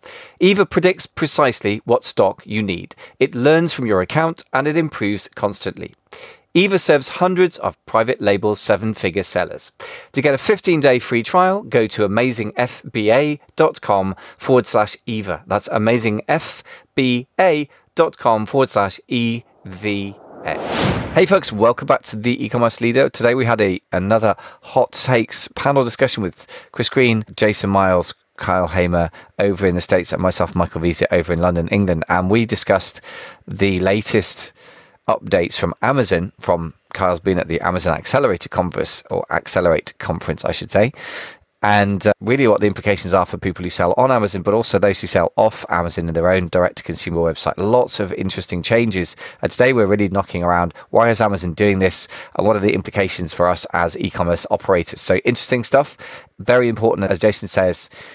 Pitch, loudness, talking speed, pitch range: 105 Hz, -18 LUFS, 165 wpm, 90-125 Hz